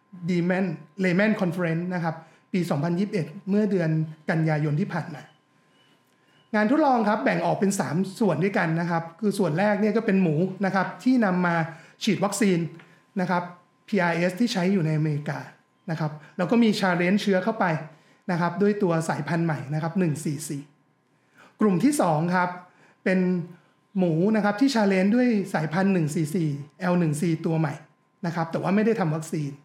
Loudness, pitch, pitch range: -25 LUFS, 180 Hz, 165-200 Hz